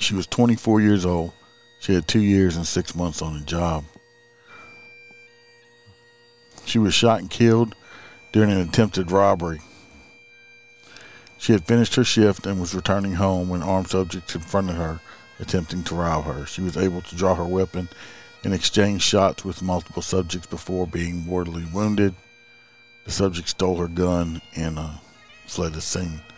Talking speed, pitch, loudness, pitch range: 155 wpm, 95 Hz, -22 LUFS, 85-110 Hz